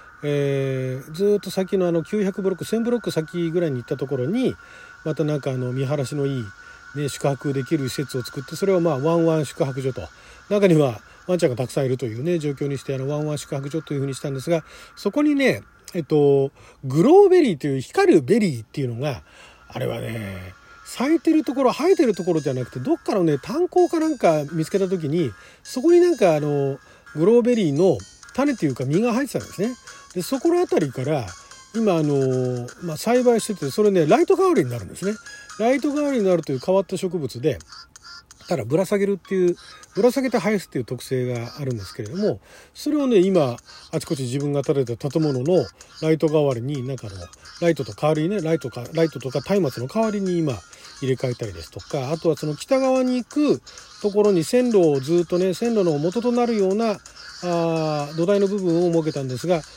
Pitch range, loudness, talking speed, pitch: 135-205 Hz, -22 LUFS, 410 characters per minute, 165 Hz